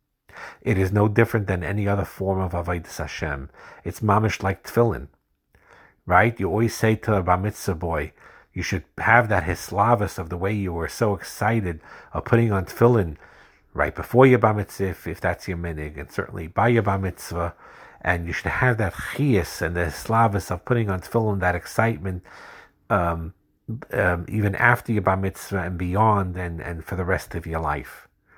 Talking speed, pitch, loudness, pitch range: 185 wpm, 95 Hz, -23 LUFS, 85-110 Hz